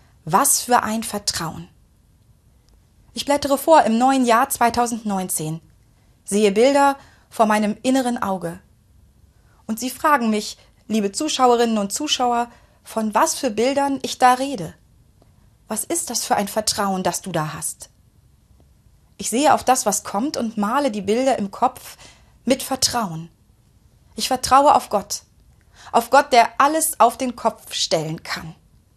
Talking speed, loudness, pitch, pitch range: 145 wpm, -19 LUFS, 225 Hz, 195-260 Hz